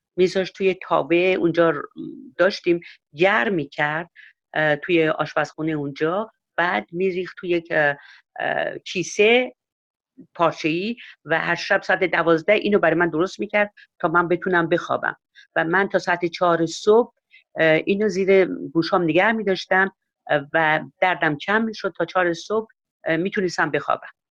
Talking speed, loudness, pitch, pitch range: 125 wpm, -21 LUFS, 175 Hz, 165-195 Hz